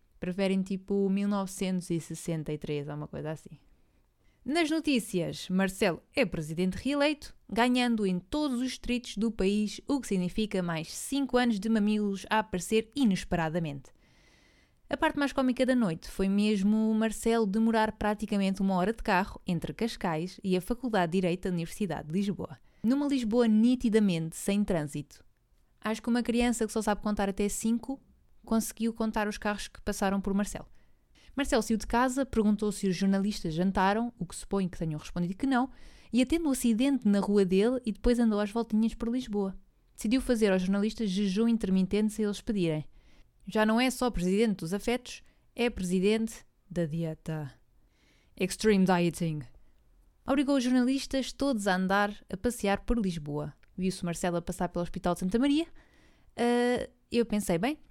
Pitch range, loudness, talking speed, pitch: 185-235 Hz, -30 LUFS, 165 wpm, 210 Hz